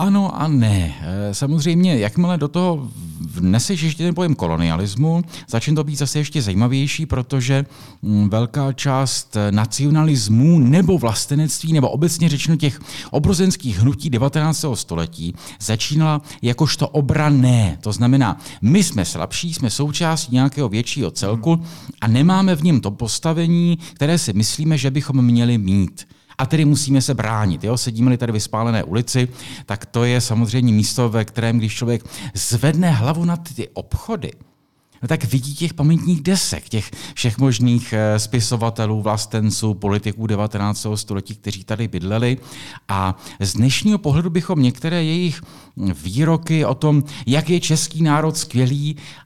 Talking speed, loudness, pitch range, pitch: 140 wpm, -18 LUFS, 110-155 Hz, 130 Hz